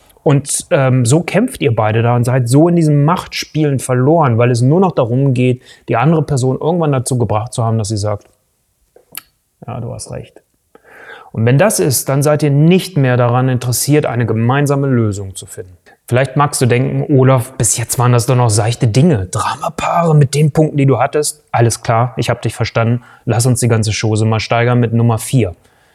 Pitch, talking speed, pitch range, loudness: 125 Hz, 200 wpm, 115-145 Hz, -13 LUFS